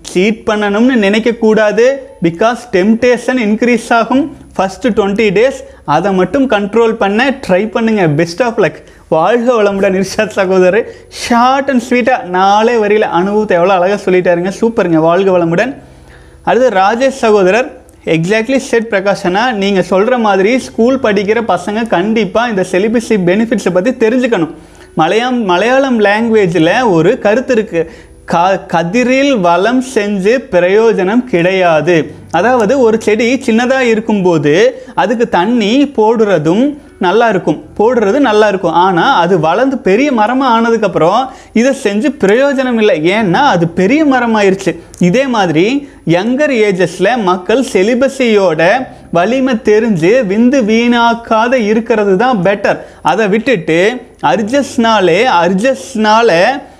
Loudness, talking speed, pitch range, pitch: -10 LUFS, 115 wpm, 190-245 Hz, 220 Hz